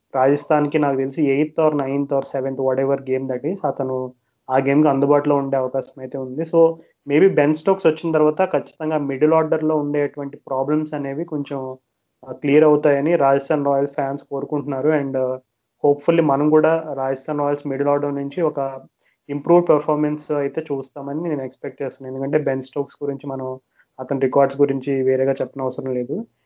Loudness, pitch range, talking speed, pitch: -20 LUFS, 135-150 Hz, 155 wpm, 140 Hz